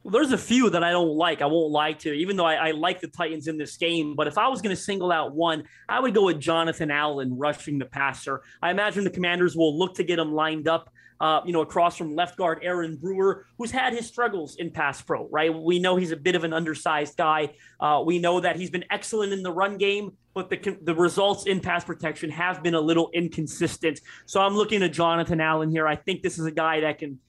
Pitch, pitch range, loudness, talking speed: 170 Hz, 155-185 Hz, -25 LUFS, 255 wpm